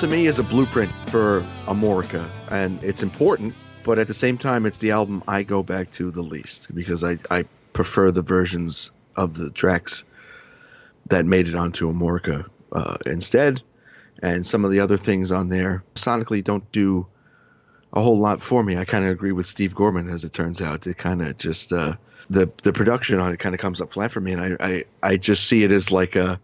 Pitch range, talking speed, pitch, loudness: 90-110 Hz, 210 wpm, 95 Hz, -22 LUFS